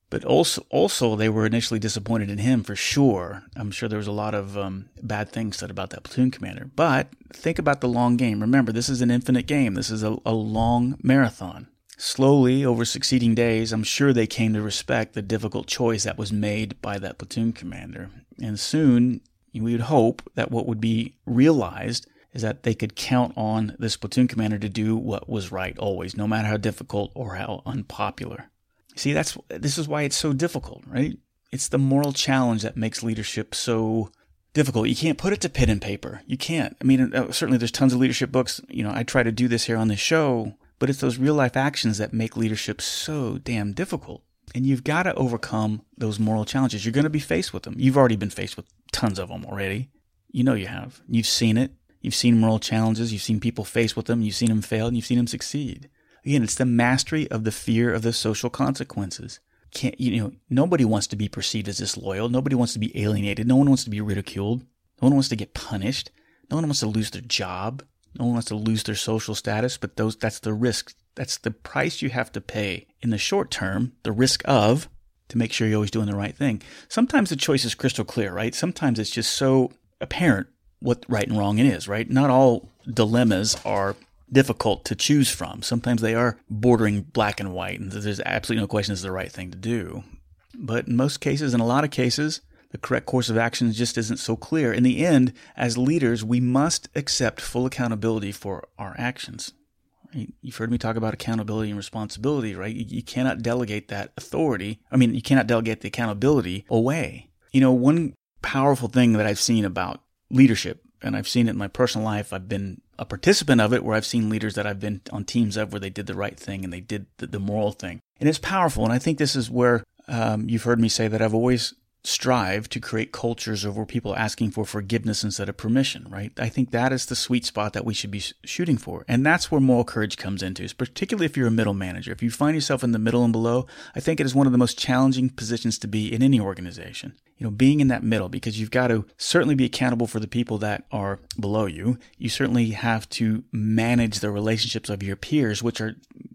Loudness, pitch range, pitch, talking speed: -23 LUFS, 105-130 Hz, 115 Hz, 225 wpm